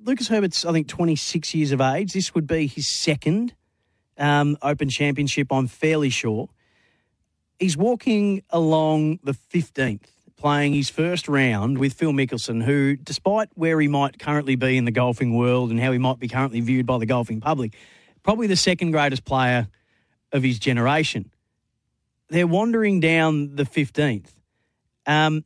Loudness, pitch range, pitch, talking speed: -22 LUFS, 125-160 Hz, 145 Hz, 160 wpm